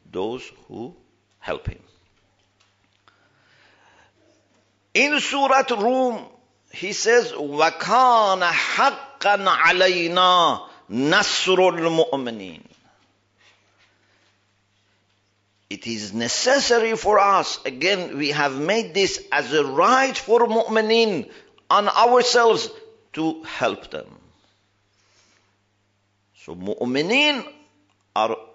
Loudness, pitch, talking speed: -19 LUFS, 160 Hz, 75 wpm